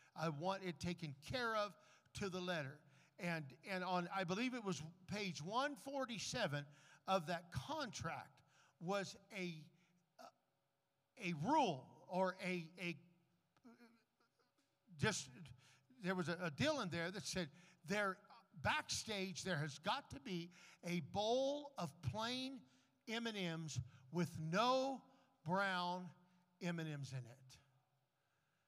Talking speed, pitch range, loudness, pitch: 115 wpm, 160-200 Hz, -44 LUFS, 180 Hz